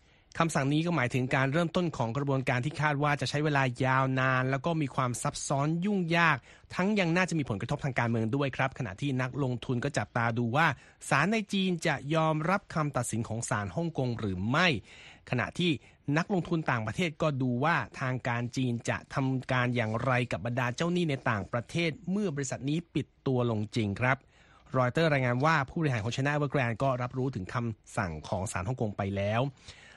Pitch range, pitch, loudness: 120-155 Hz, 135 Hz, -30 LUFS